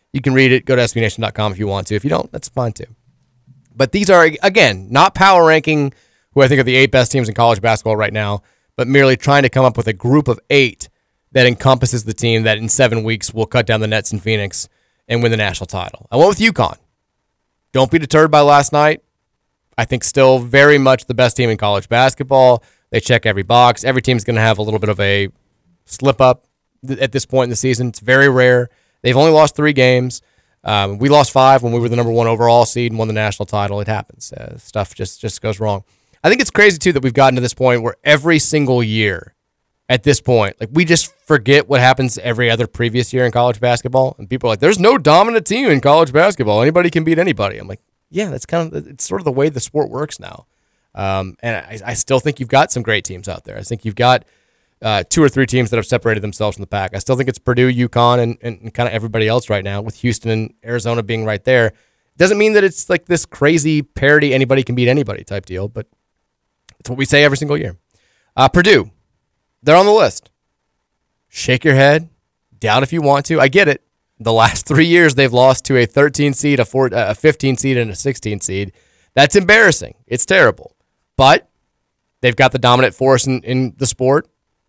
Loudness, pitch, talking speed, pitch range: -13 LUFS, 125 Hz, 230 wpm, 110-140 Hz